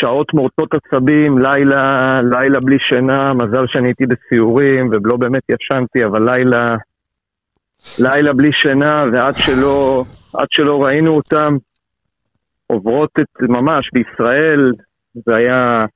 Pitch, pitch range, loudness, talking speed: 130 Hz, 125-140 Hz, -13 LUFS, 115 wpm